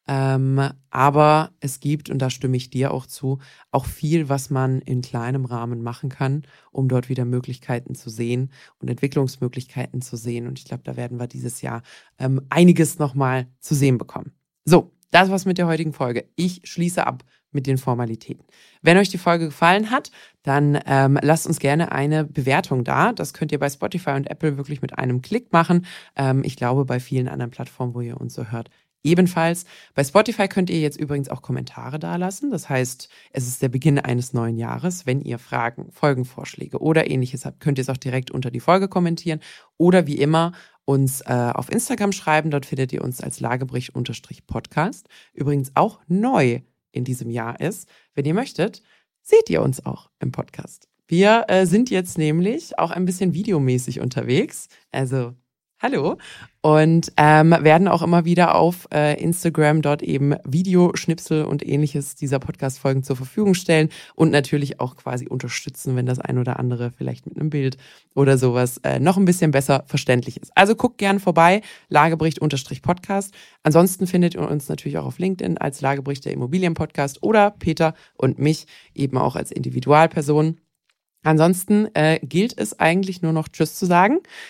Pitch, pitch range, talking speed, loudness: 145 Hz, 130-170 Hz, 180 wpm, -20 LUFS